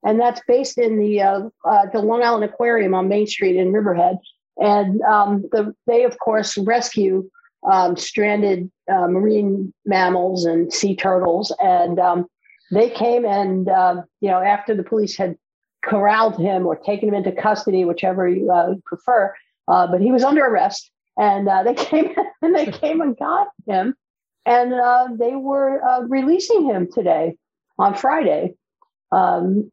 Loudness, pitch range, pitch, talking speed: -18 LUFS, 190-245 Hz, 210 Hz, 165 wpm